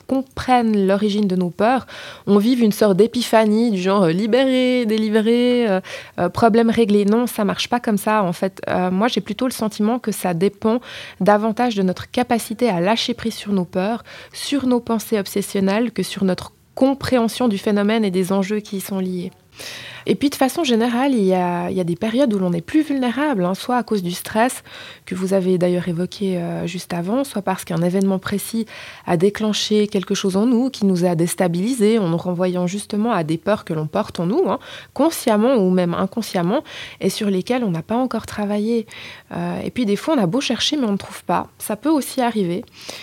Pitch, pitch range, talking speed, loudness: 210 Hz, 190-240 Hz, 210 wpm, -19 LUFS